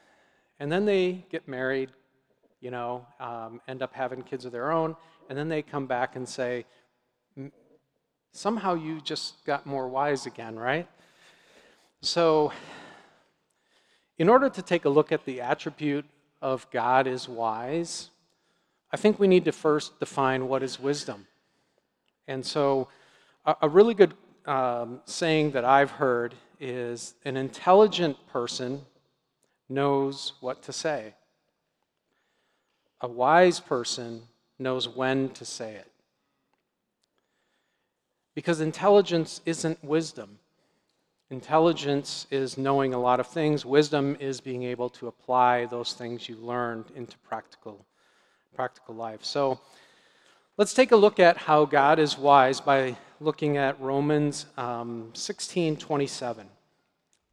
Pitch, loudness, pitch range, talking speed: 135 Hz, -26 LUFS, 125-155 Hz, 130 wpm